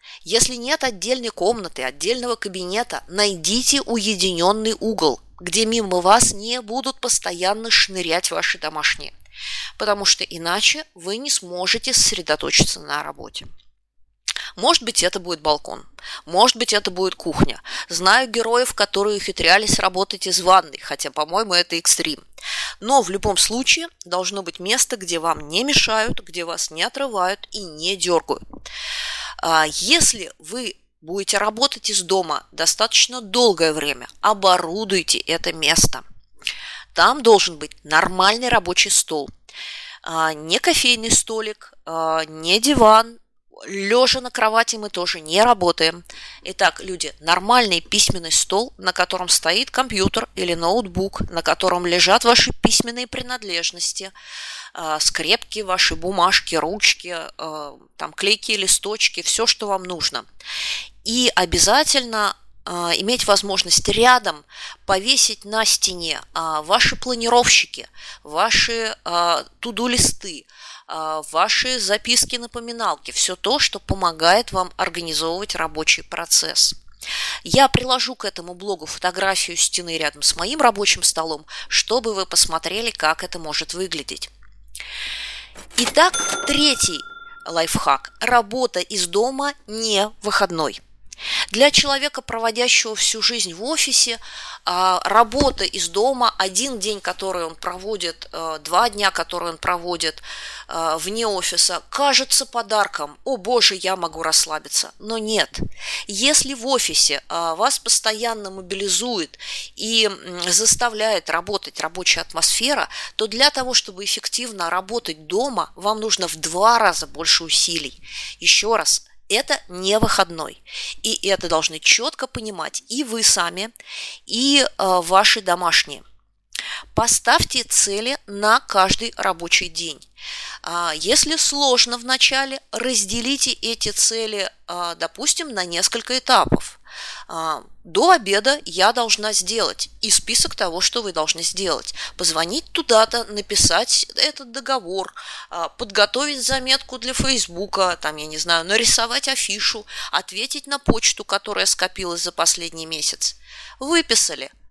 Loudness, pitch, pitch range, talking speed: -18 LUFS, 205 Hz, 175-240 Hz, 115 wpm